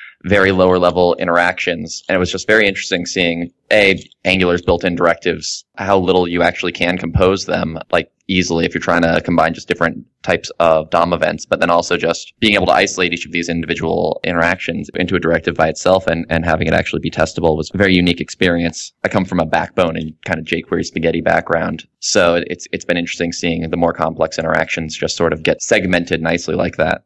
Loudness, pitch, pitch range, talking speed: -16 LUFS, 85 Hz, 80-90 Hz, 210 wpm